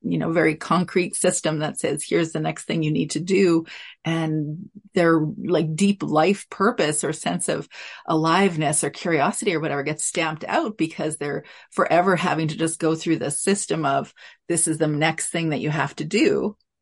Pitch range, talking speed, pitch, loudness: 155-180 Hz, 190 wpm, 160 Hz, -22 LUFS